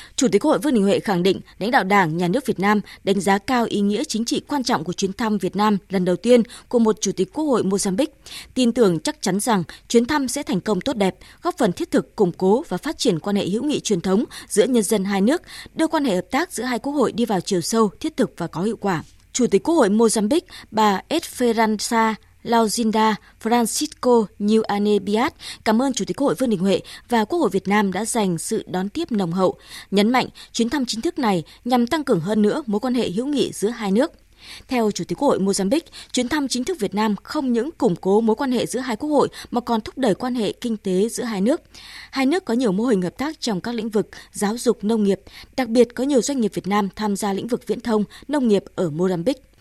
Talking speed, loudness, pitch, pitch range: 255 wpm, -21 LUFS, 220 Hz, 200-250 Hz